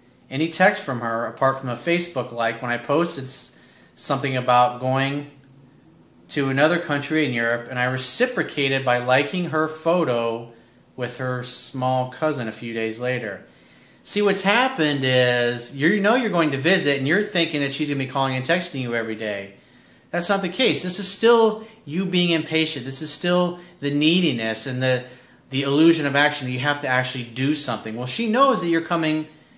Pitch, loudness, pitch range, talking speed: 140 Hz, -21 LUFS, 125-165 Hz, 190 wpm